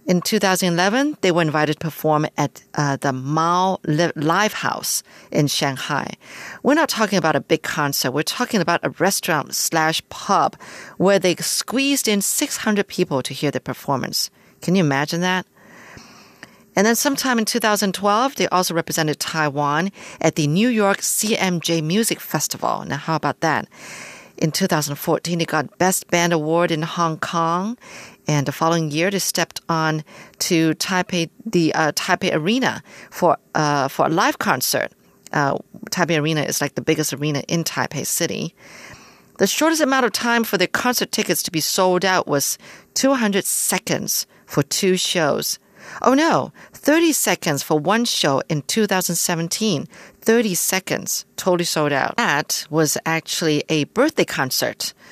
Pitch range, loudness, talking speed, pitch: 155-205 Hz, -20 LUFS, 155 wpm, 170 Hz